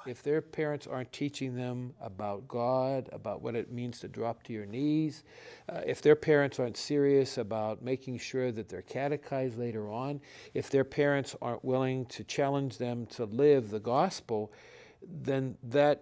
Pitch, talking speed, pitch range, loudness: 130 Hz, 170 wpm, 120-140 Hz, -32 LUFS